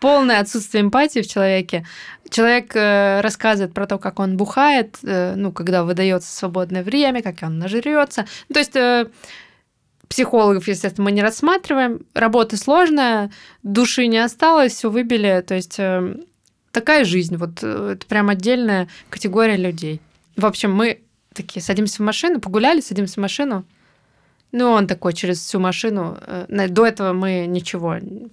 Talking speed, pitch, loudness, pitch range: 155 wpm, 205 Hz, -18 LUFS, 185-235 Hz